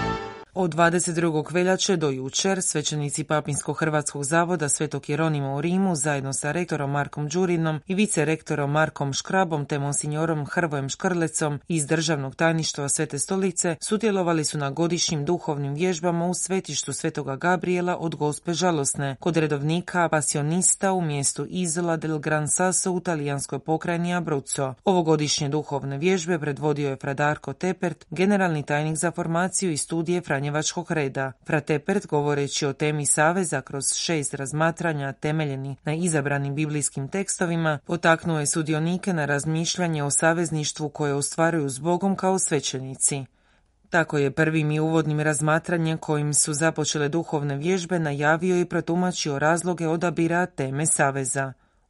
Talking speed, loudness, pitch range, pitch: 135 wpm, -24 LUFS, 145-175 Hz, 155 Hz